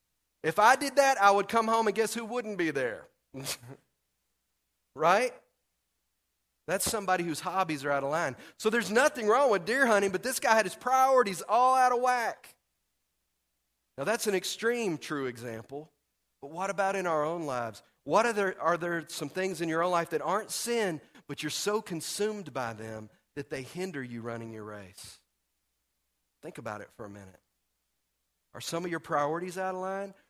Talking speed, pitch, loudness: 185 wpm, 165 Hz, -29 LUFS